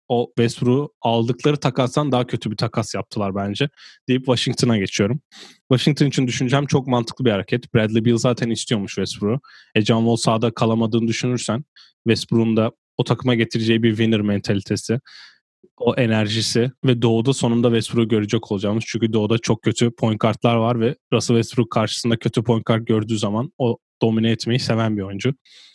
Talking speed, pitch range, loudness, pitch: 160 wpm, 110-125 Hz, -20 LUFS, 115 Hz